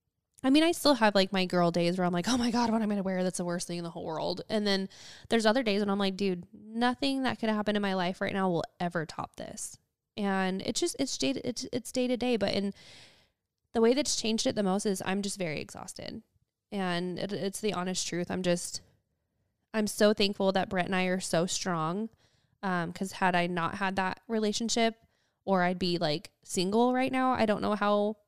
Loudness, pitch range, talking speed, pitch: -30 LUFS, 175-220 Hz, 240 wpm, 195 Hz